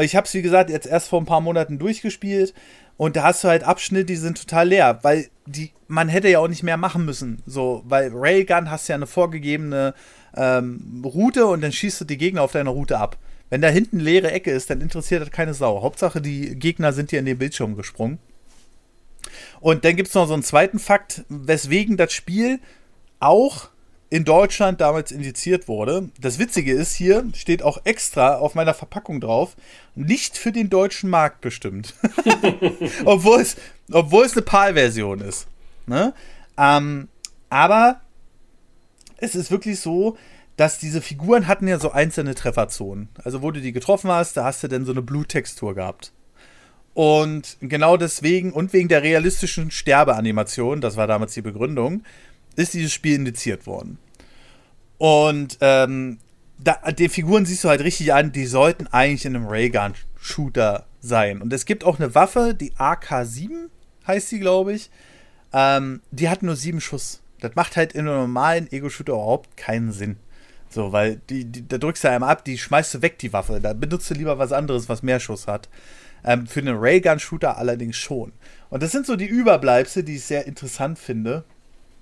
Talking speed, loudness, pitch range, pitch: 180 wpm, -20 LUFS, 130-180 Hz, 150 Hz